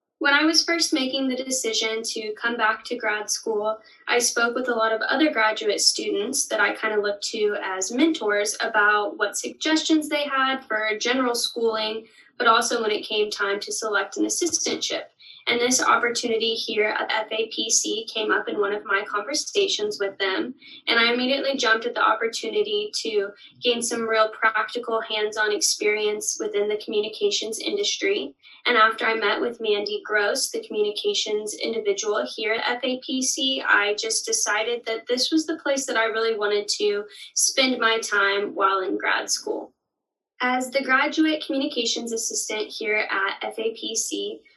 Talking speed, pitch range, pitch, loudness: 165 wpm, 220-330 Hz, 240 Hz, -23 LUFS